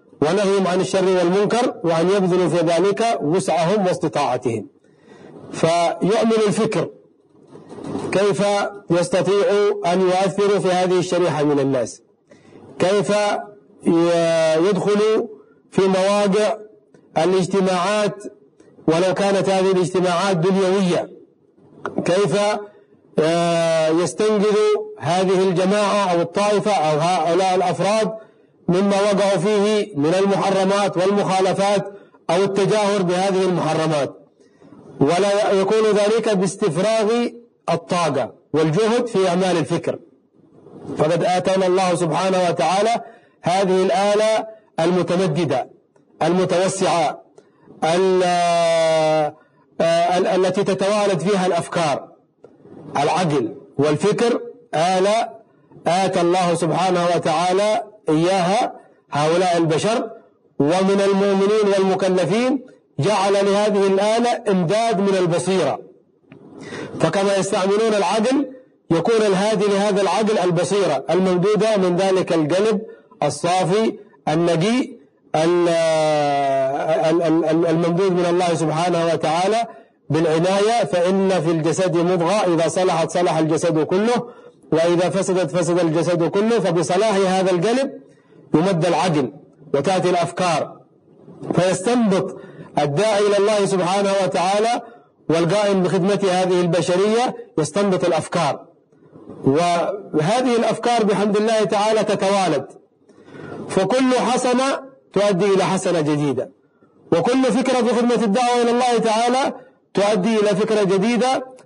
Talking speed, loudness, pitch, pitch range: 90 wpm, -18 LUFS, 190 Hz, 175-210 Hz